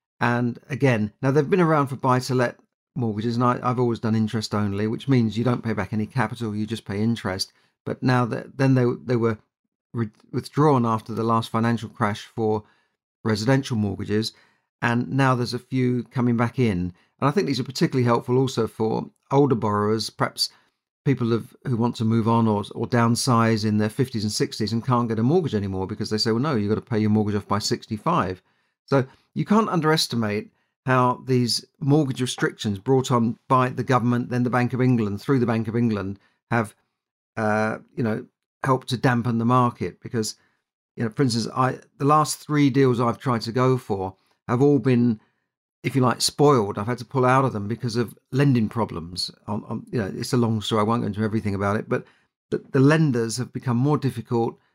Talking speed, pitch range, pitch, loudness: 205 wpm, 110-130 Hz, 120 Hz, -23 LUFS